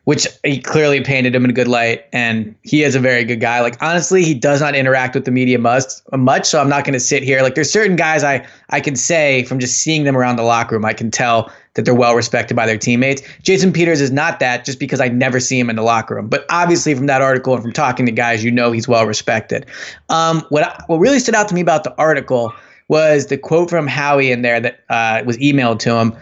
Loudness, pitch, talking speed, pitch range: -14 LUFS, 130 Hz, 260 wpm, 120-150 Hz